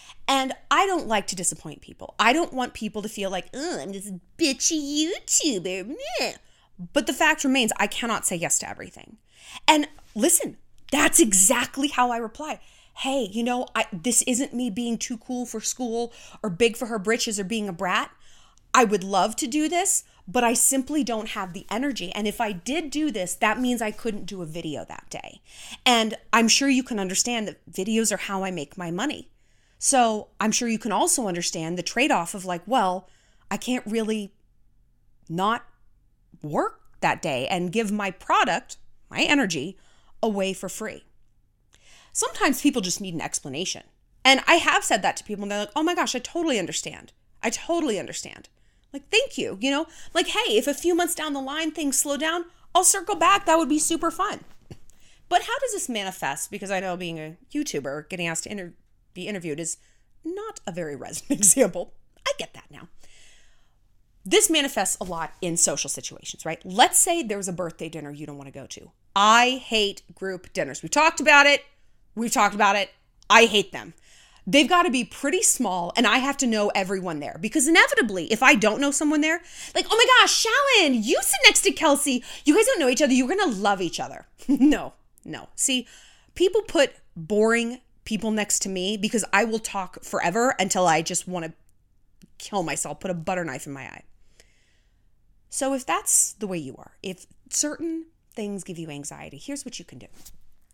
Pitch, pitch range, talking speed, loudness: 230 Hz, 190-290 Hz, 195 wpm, -23 LUFS